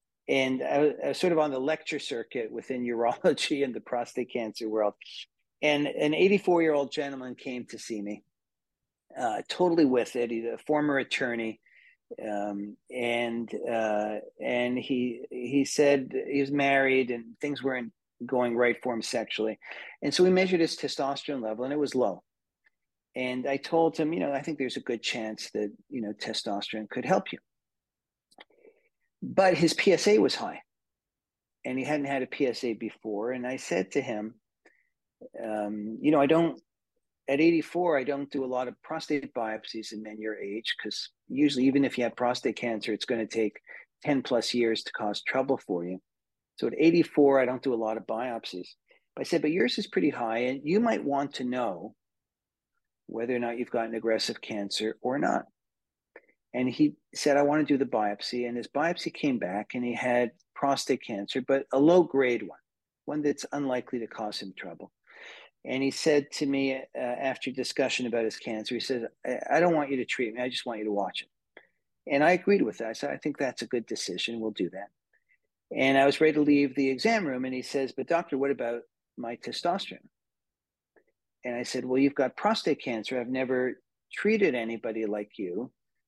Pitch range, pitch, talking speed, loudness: 115-145 Hz, 125 Hz, 195 wpm, -28 LUFS